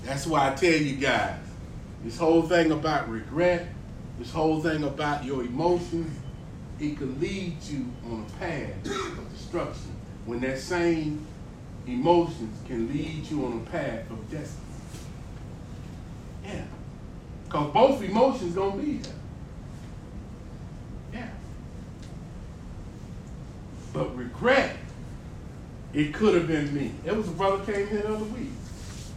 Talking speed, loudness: 130 wpm, -27 LUFS